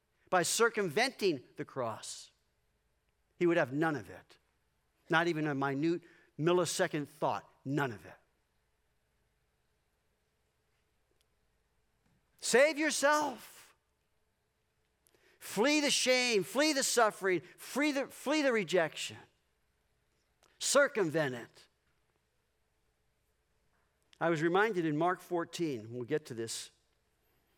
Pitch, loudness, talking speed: 160 Hz, -32 LUFS, 95 wpm